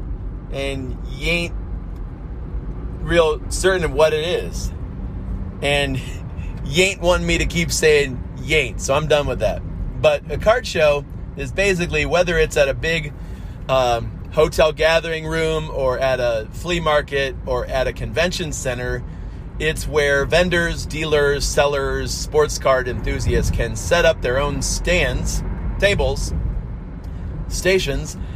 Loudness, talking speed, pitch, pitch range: -19 LUFS, 140 wpm, 145 Hz, 120-160 Hz